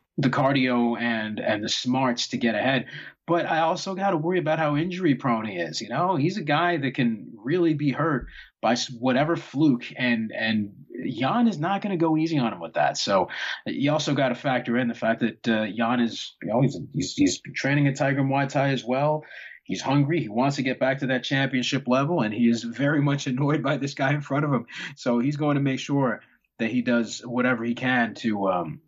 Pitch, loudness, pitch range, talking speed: 135 Hz, -24 LUFS, 120-150 Hz, 230 wpm